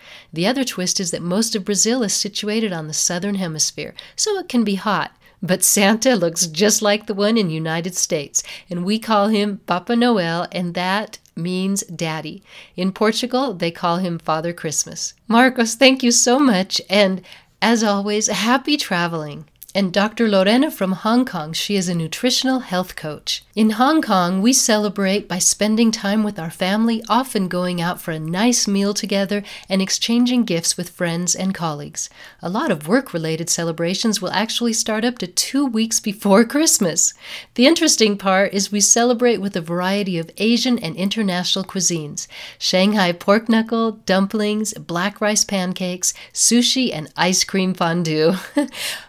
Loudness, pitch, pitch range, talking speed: -18 LUFS, 200 Hz, 180-225 Hz, 165 wpm